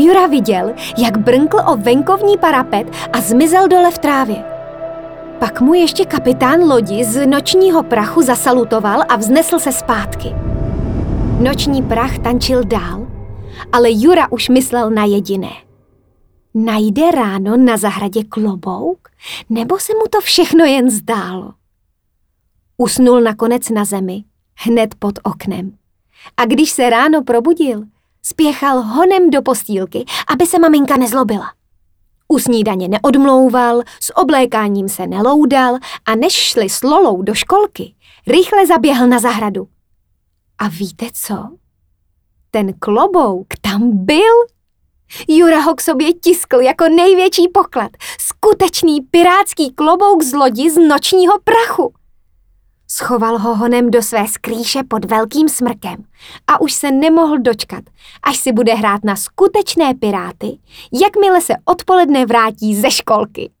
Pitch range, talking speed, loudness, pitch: 215-330 Hz, 125 wpm, -12 LUFS, 250 Hz